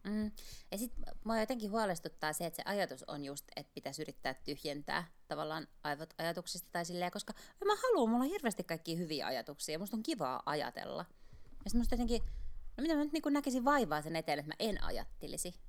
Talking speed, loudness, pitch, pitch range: 200 wpm, -38 LUFS, 200 Hz, 160-240 Hz